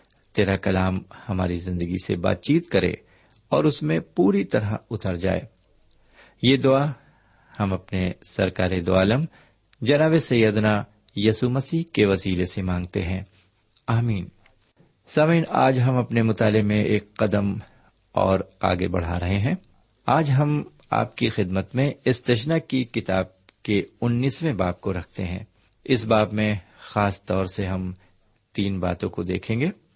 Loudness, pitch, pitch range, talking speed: -23 LUFS, 105 Hz, 95-120 Hz, 145 wpm